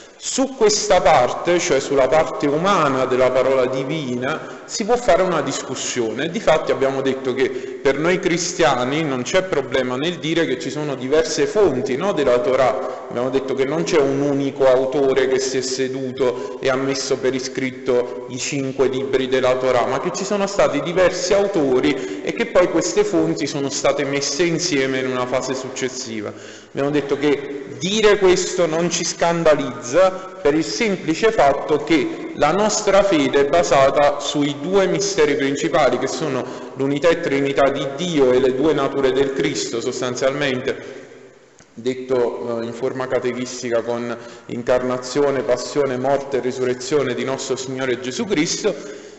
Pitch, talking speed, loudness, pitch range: 135 Hz, 155 wpm, -19 LUFS, 130-170 Hz